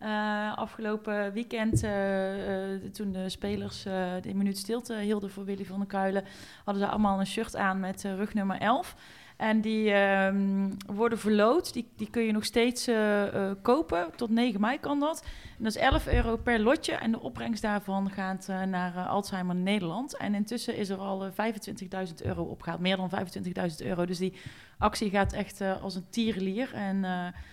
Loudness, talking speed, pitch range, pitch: -30 LUFS, 195 wpm, 195-220 Hz, 200 Hz